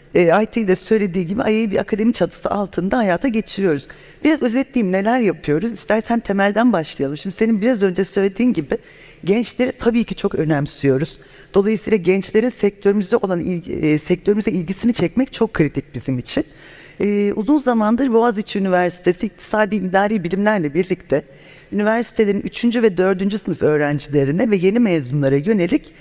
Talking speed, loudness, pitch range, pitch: 140 wpm, -18 LUFS, 175-225 Hz, 200 Hz